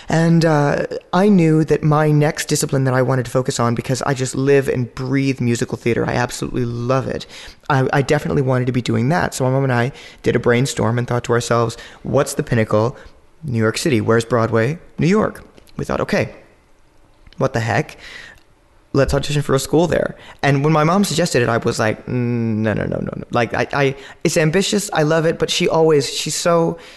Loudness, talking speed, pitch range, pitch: -18 LUFS, 215 wpm, 120-155 Hz, 135 Hz